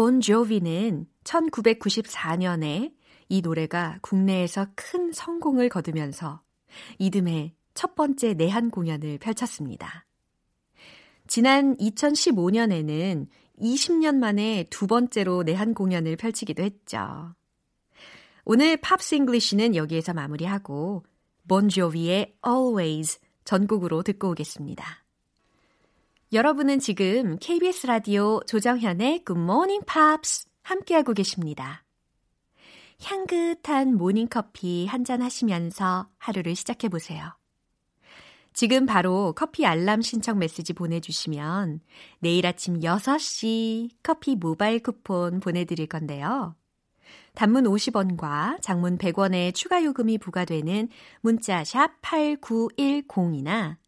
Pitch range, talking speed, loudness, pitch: 175-245 Hz, 240 characters per minute, -25 LUFS, 205 Hz